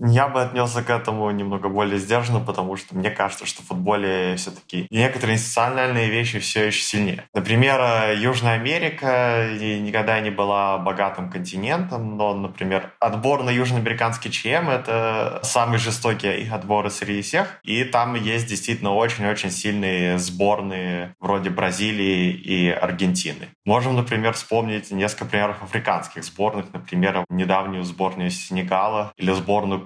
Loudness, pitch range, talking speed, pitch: -22 LUFS, 95-115 Hz, 135 wpm, 105 Hz